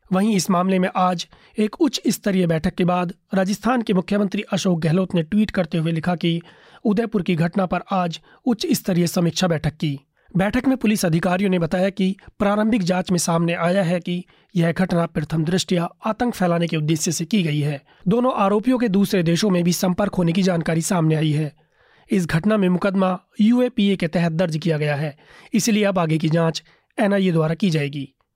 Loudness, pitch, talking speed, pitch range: -20 LUFS, 185 Hz, 195 wpm, 170-205 Hz